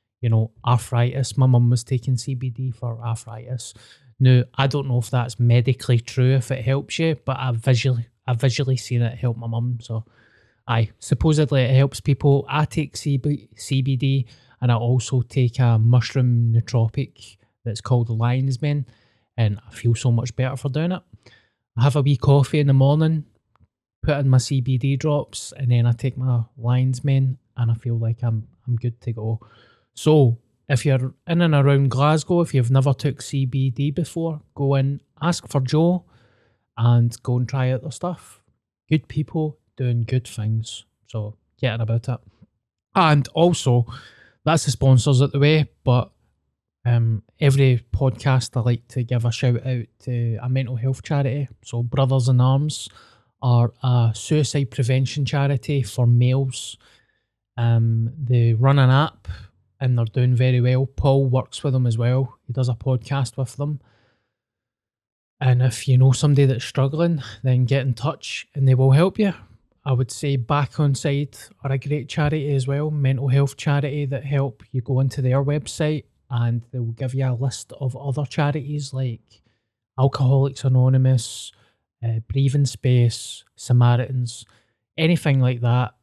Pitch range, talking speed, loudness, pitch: 120-140 Hz, 165 wpm, -21 LUFS, 130 Hz